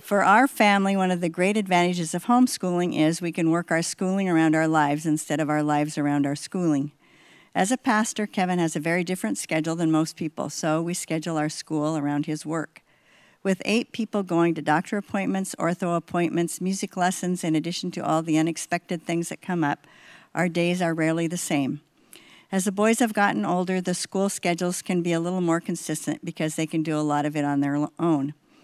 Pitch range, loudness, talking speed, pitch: 155-185 Hz, -24 LUFS, 205 wpm, 170 Hz